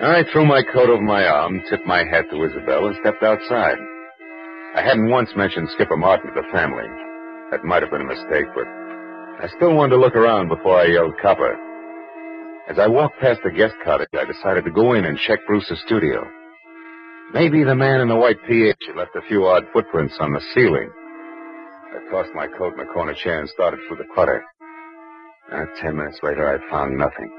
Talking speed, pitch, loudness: 200 wpm, 170 Hz, -18 LUFS